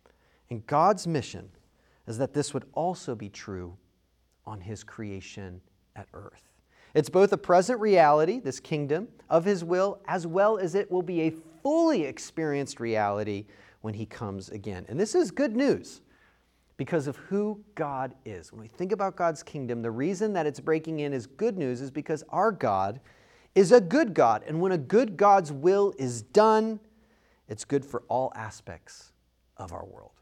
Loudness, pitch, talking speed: -26 LUFS, 145 Hz, 175 wpm